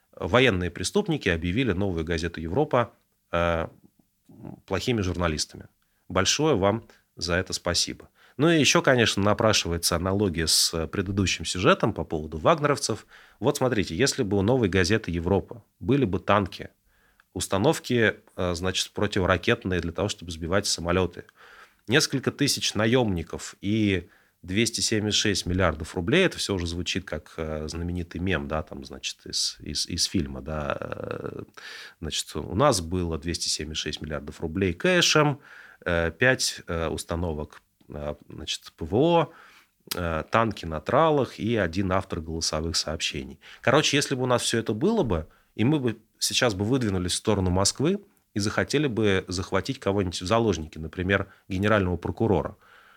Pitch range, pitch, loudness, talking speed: 85-115 Hz, 95 Hz, -25 LUFS, 130 wpm